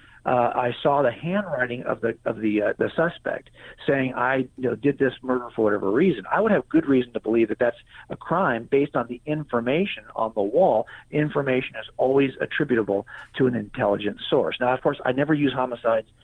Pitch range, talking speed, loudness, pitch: 115-140 Hz, 205 wpm, -24 LUFS, 125 Hz